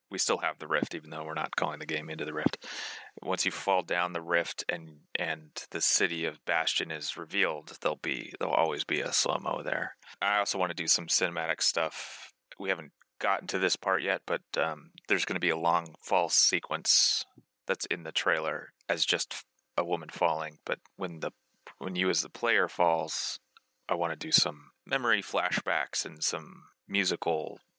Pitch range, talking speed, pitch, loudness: 80-90 Hz, 195 wpm, 85 Hz, -30 LUFS